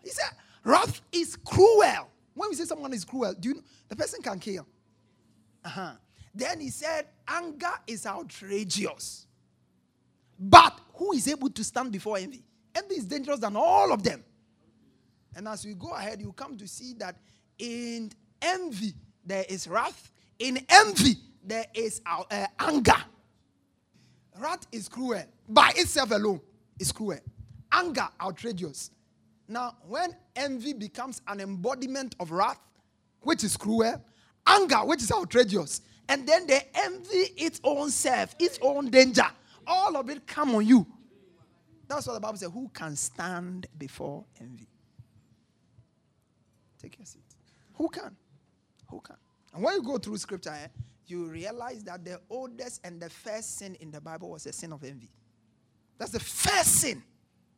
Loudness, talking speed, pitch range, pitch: -26 LUFS, 155 wpm, 180-280 Hz, 225 Hz